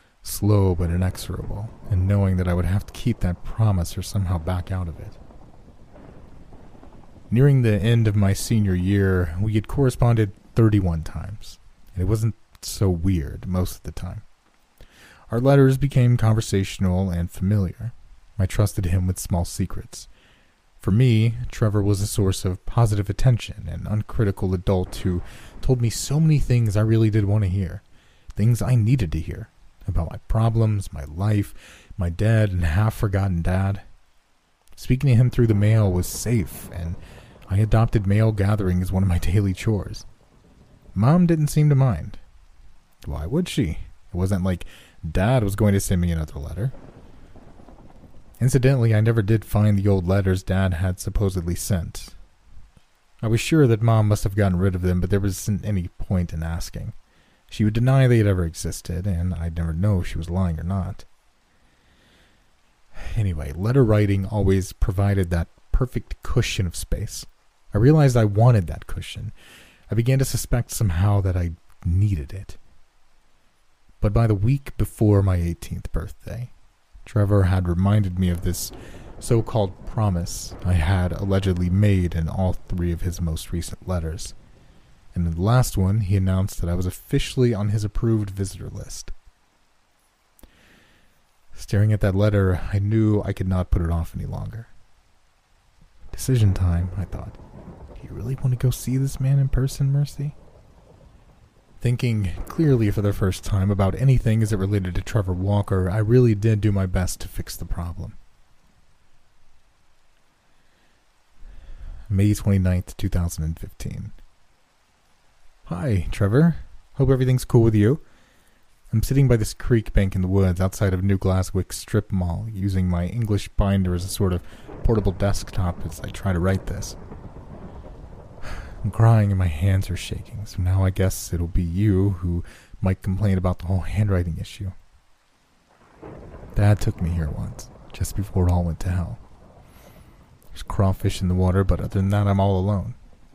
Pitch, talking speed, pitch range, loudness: 95 Hz, 165 wpm, 90-110 Hz, -22 LUFS